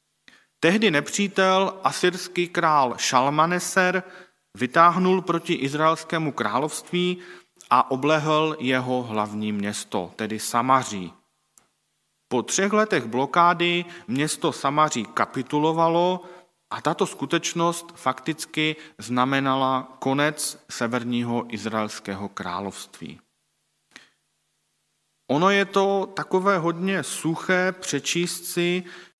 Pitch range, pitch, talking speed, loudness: 130-180 Hz, 155 Hz, 80 wpm, -23 LUFS